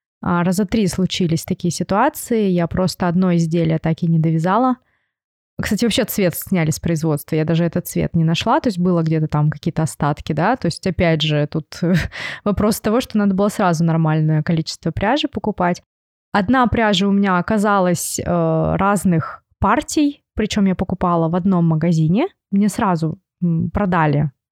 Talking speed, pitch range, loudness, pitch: 155 wpm, 165-205 Hz, -18 LUFS, 180 Hz